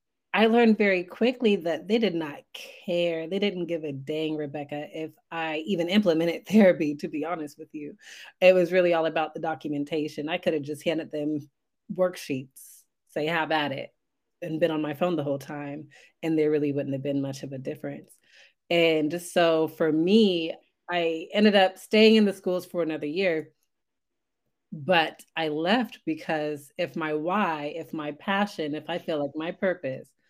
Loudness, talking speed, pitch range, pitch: -26 LUFS, 180 wpm, 150-180 Hz, 165 Hz